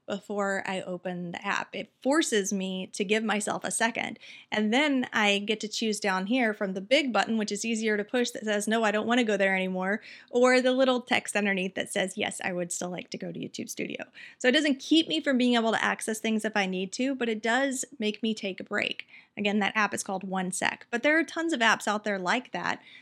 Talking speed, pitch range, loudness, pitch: 250 wpm, 195-250 Hz, -27 LUFS, 215 Hz